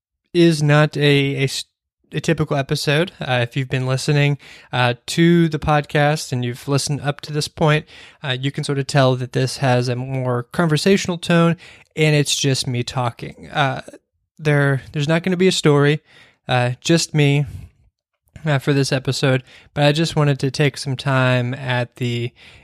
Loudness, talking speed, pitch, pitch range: -19 LUFS, 180 wpm, 140 Hz, 125-150 Hz